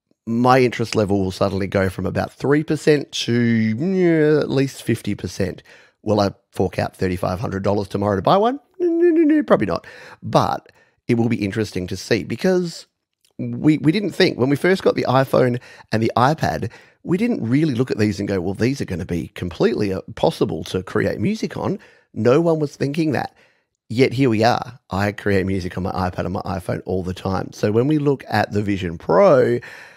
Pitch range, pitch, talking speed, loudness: 95-140 Hz, 115 Hz, 200 wpm, -20 LUFS